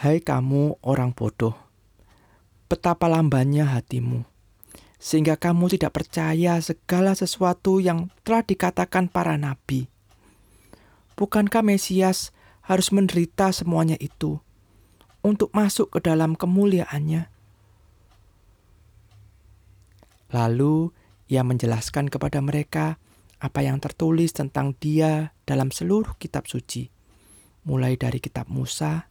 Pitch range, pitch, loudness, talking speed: 105-170 Hz, 145 Hz, -23 LUFS, 95 wpm